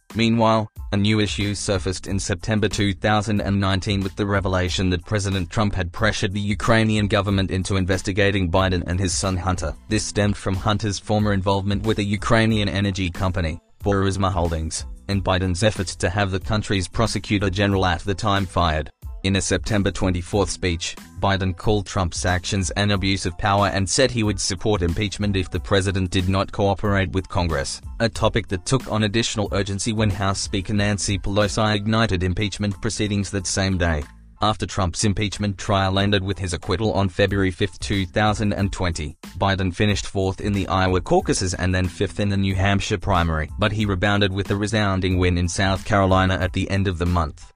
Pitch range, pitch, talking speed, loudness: 95-105 Hz, 100 Hz, 175 wpm, -22 LUFS